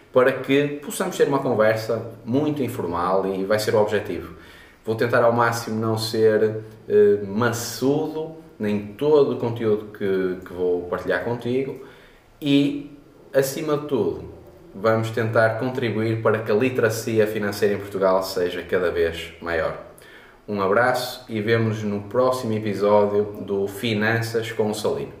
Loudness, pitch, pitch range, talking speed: -22 LUFS, 110 Hz, 105-125 Hz, 145 wpm